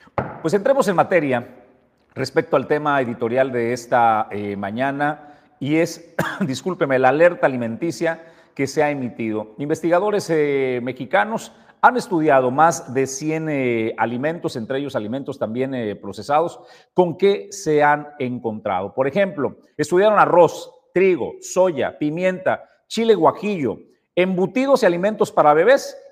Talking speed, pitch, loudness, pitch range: 130 wpm, 150 Hz, -20 LUFS, 130-180 Hz